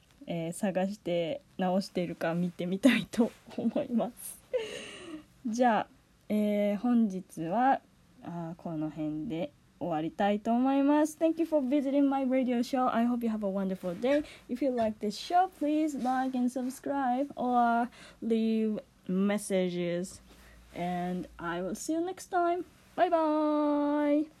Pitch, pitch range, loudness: 235 Hz, 185-285 Hz, -31 LUFS